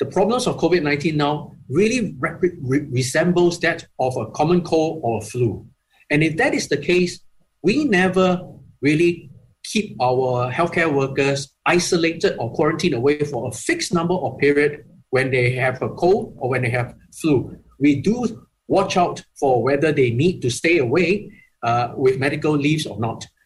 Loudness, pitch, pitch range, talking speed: -20 LUFS, 150 Hz, 130-175 Hz, 170 wpm